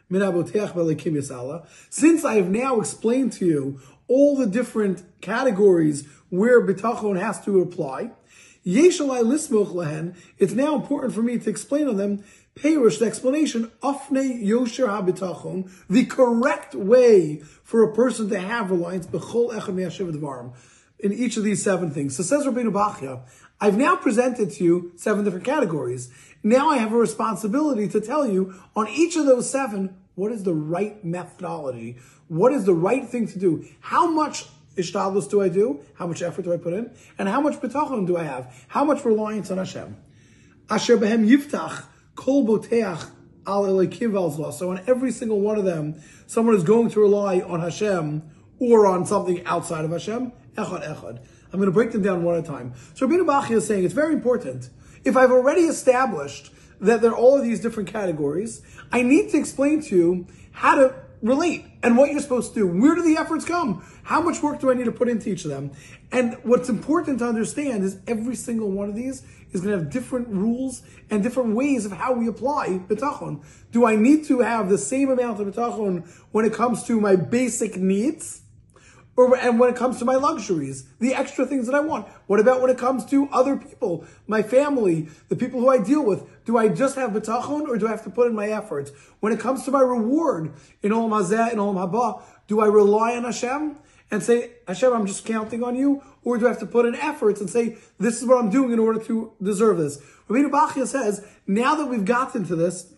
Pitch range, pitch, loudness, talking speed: 185-255 Hz, 220 Hz, -22 LUFS, 190 wpm